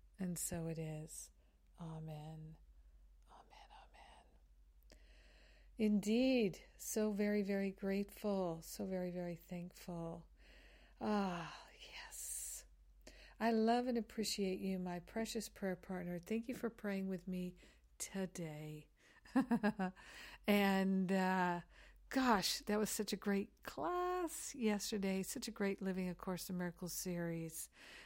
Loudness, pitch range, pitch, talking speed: -41 LUFS, 165-210 Hz, 190 Hz, 115 wpm